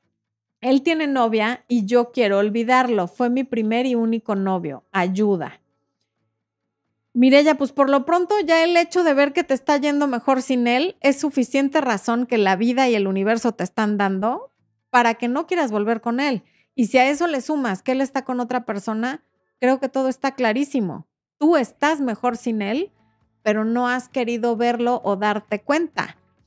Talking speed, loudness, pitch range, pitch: 180 wpm, -20 LUFS, 215-275 Hz, 245 Hz